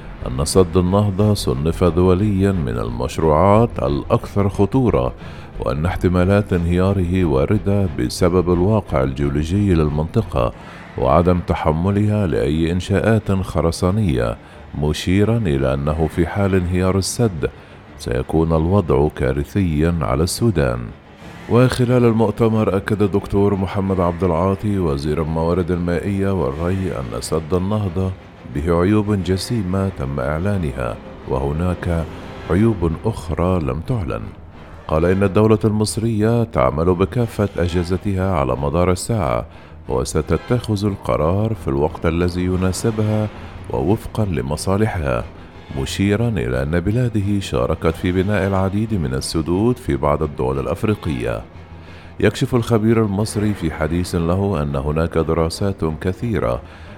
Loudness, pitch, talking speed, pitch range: -19 LUFS, 90 Hz, 105 wpm, 80-100 Hz